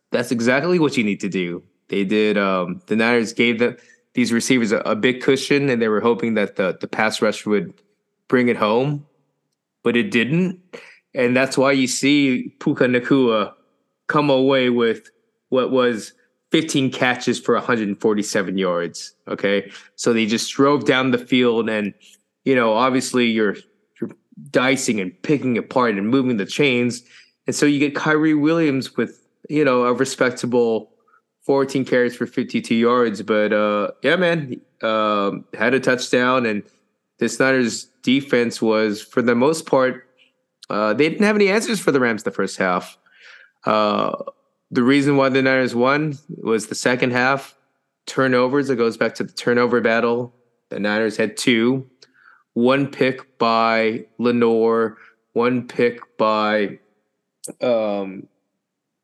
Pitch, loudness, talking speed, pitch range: 125 Hz, -19 LUFS, 155 wpm, 110-135 Hz